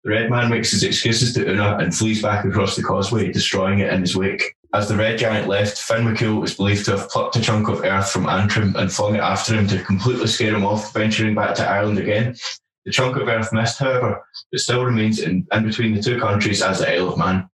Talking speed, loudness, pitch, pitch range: 245 wpm, -19 LUFS, 105 Hz, 100-115 Hz